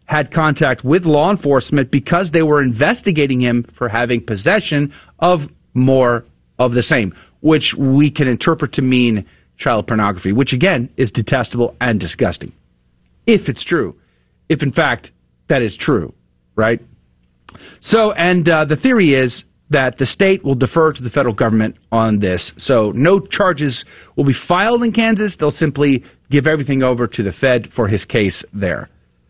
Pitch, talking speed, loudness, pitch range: 130 Hz, 160 wpm, -15 LUFS, 115-155 Hz